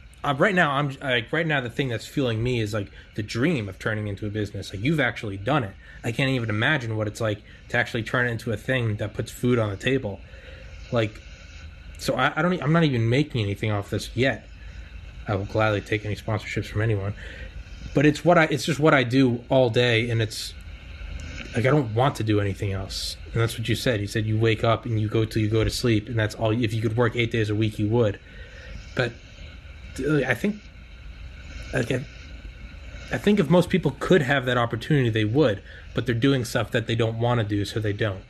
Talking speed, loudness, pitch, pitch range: 230 wpm, -24 LUFS, 110 Hz, 95-125 Hz